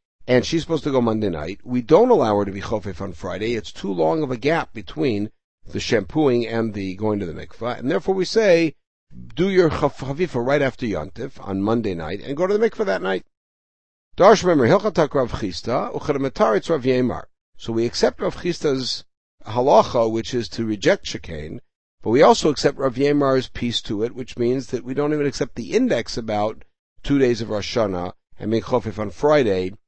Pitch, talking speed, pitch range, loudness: 125 Hz, 180 wpm, 110-145 Hz, -21 LUFS